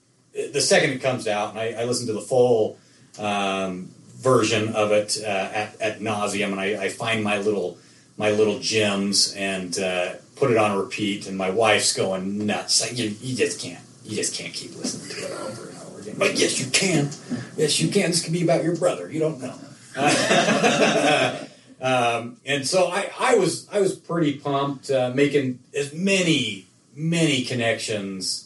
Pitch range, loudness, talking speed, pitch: 105-145 Hz, -22 LUFS, 190 wpm, 115 Hz